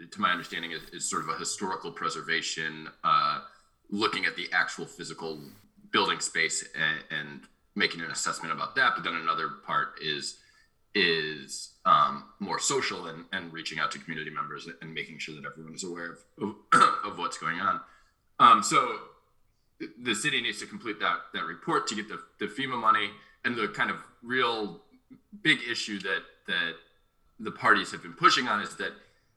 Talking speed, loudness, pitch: 175 wpm, -28 LUFS, 85 Hz